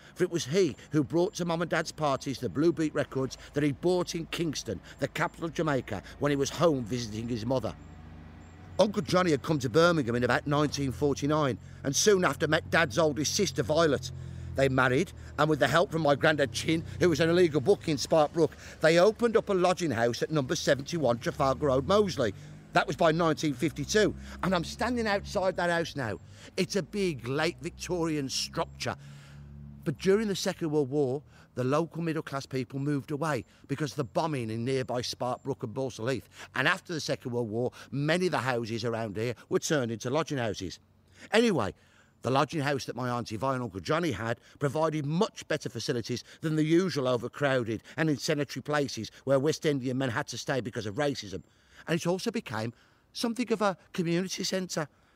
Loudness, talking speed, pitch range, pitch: -29 LUFS, 190 wpm, 125-165 Hz, 145 Hz